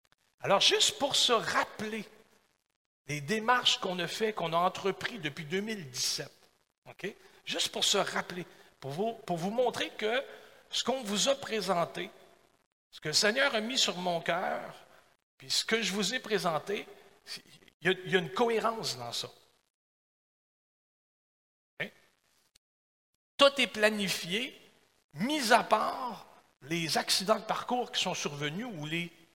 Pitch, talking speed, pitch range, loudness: 200 Hz, 150 wpm, 170-225 Hz, -30 LUFS